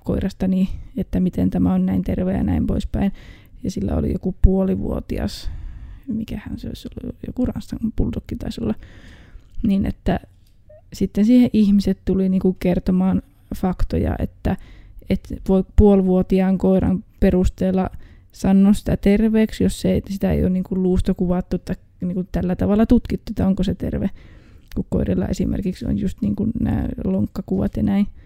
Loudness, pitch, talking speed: -20 LUFS, 190 Hz, 145 wpm